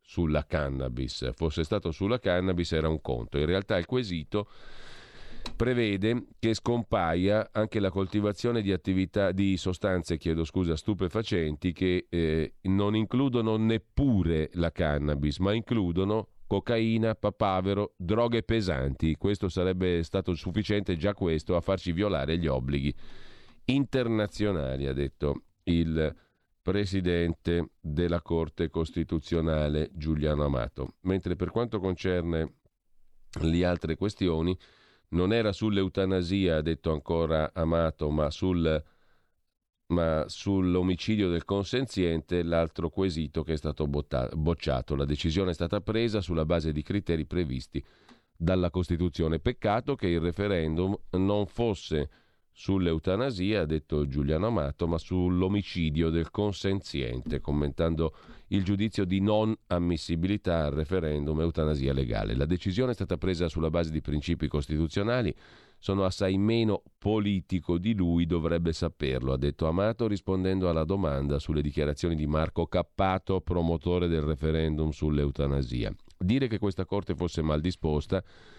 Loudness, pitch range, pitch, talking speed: -29 LUFS, 80-100 Hz, 90 Hz, 125 wpm